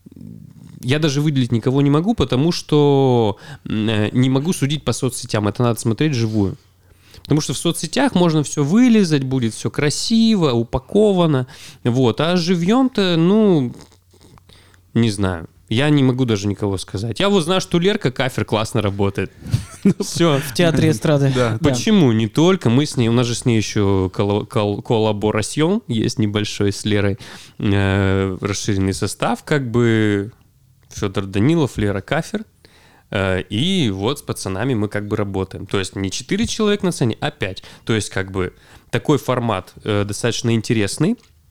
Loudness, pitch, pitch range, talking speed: -18 LUFS, 120 Hz, 105-150 Hz, 145 wpm